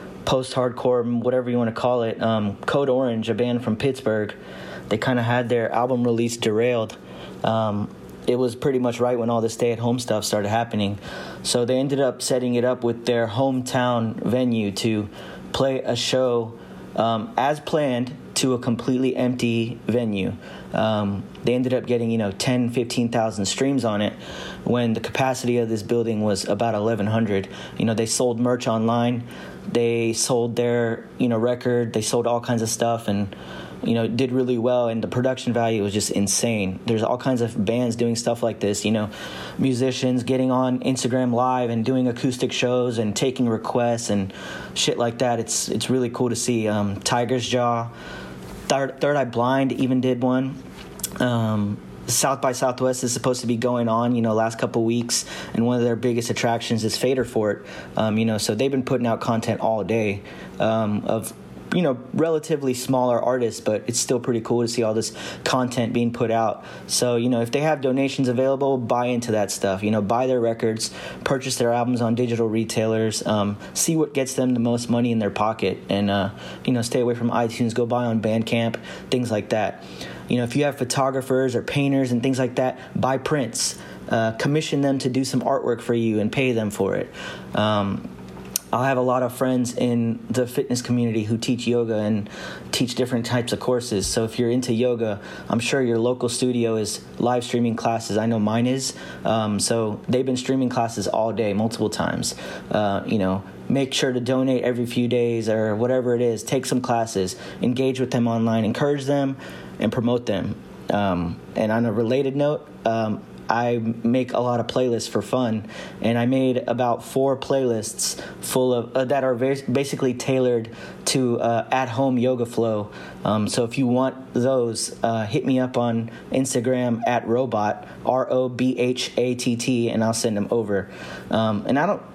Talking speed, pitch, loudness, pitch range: 195 wpm, 120 Hz, -23 LUFS, 110-125 Hz